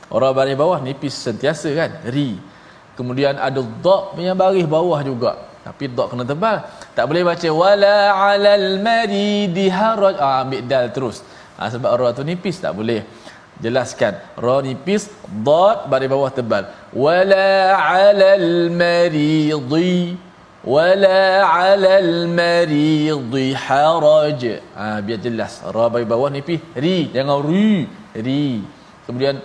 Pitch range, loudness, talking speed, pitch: 135-190 Hz, -16 LUFS, 125 wpm, 165 Hz